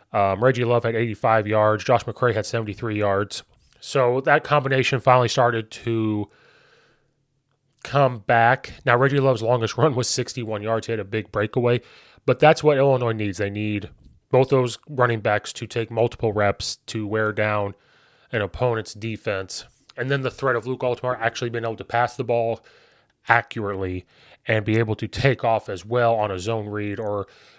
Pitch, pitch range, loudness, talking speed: 115 Hz, 105-125 Hz, -22 LUFS, 175 wpm